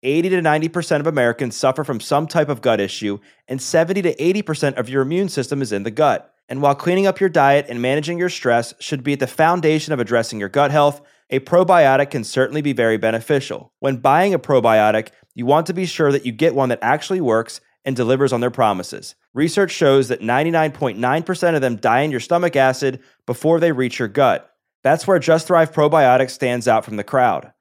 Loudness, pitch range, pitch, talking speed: -18 LUFS, 125-160 Hz, 140 Hz, 215 wpm